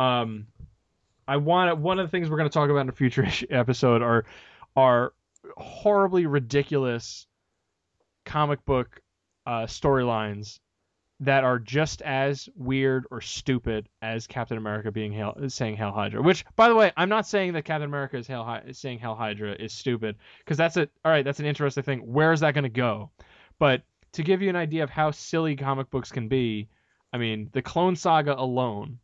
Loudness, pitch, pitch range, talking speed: -25 LUFS, 130 Hz, 115-150 Hz, 185 wpm